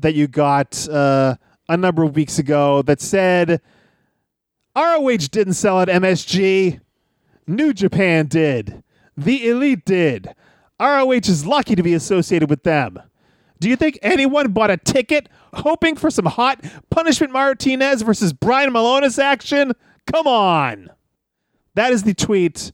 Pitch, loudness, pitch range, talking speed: 190 Hz, -17 LUFS, 160-265 Hz, 140 wpm